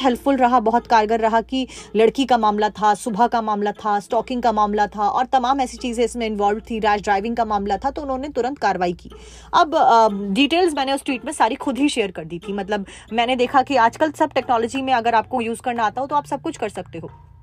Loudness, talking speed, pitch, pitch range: -20 LUFS, 240 wpm, 235 Hz, 210-265 Hz